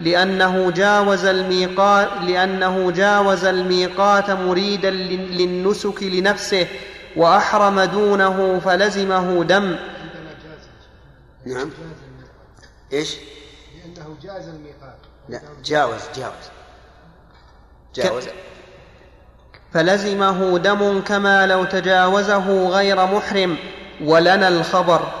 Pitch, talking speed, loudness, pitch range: 185 Hz, 70 wpm, -17 LUFS, 170-195 Hz